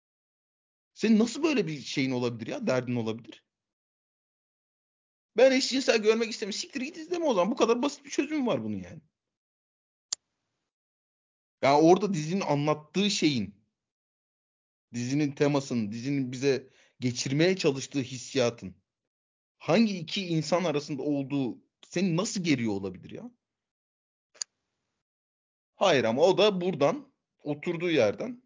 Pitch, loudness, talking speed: 155 Hz, -28 LUFS, 120 wpm